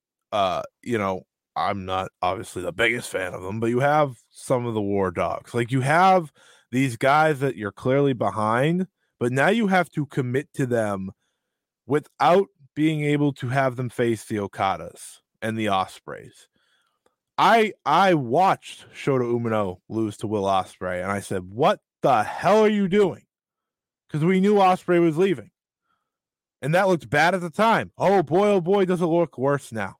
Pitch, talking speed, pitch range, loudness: 135 Hz, 175 wpm, 110-175 Hz, -22 LUFS